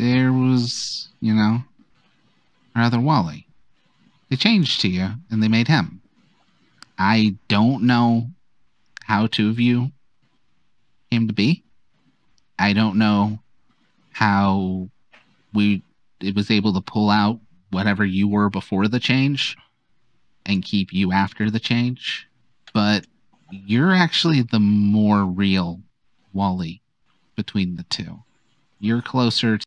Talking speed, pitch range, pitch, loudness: 120 wpm, 100-120 Hz, 110 Hz, -20 LUFS